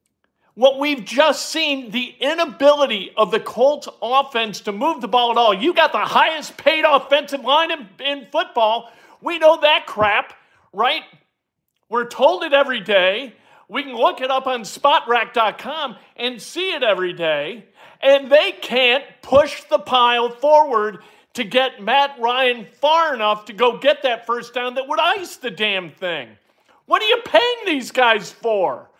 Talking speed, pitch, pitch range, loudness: 165 wpm, 265 Hz, 230-295 Hz, -18 LUFS